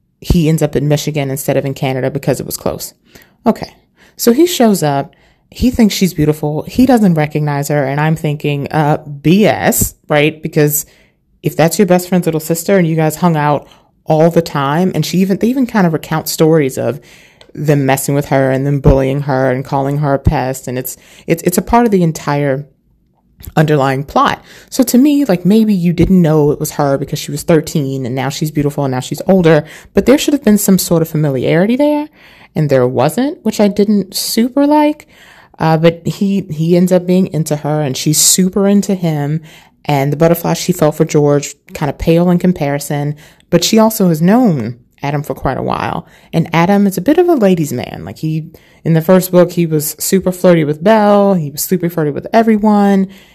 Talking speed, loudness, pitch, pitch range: 210 wpm, -13 LUFS, 160 Hz, 145-190 Hz